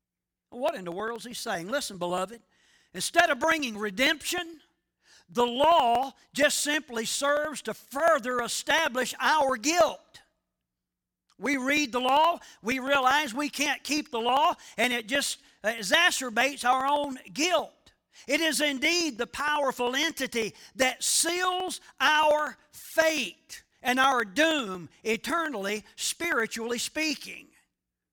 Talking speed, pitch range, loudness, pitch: 120 wpm, 235-305 Hz, -26 LUFS, 270 Hz